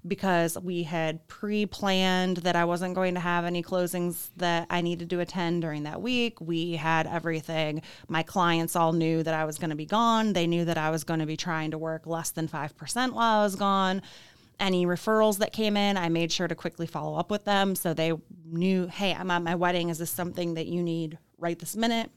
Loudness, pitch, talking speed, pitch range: -28 LUFS, 175 Hz, 225 wpm, 165-185 Hz